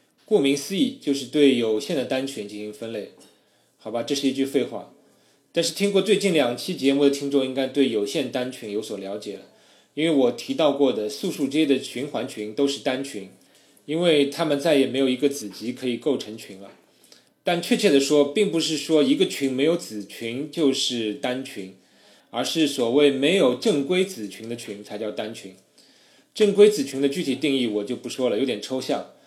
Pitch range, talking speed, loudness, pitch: 110-150 Hz, 285 characters per minute, -23 LUFS, 135 Hz